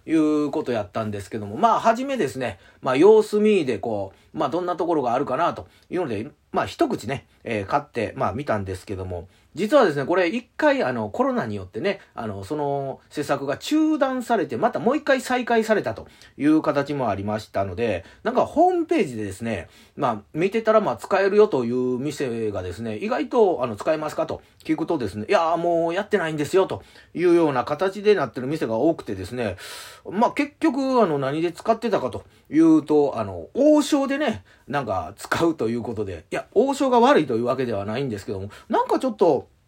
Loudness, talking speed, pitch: -23 LUFS, 405 characters per minute, 165 Hz